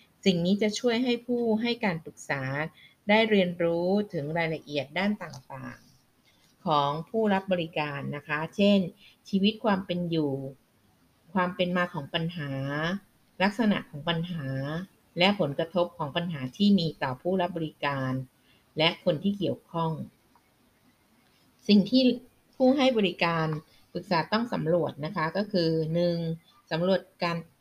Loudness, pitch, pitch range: -28 LUFS, 170 Hz, 150-195 Hz